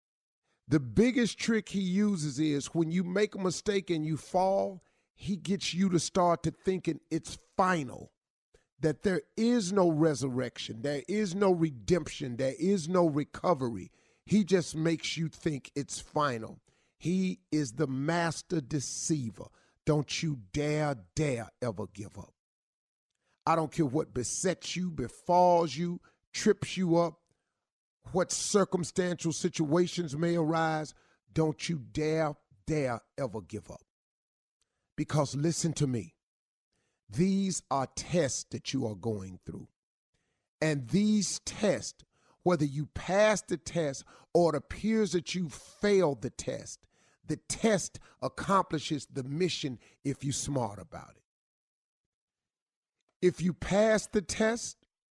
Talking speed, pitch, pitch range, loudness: 130 wpm, 160 Hz, 140-180 Hz, -31 LUFS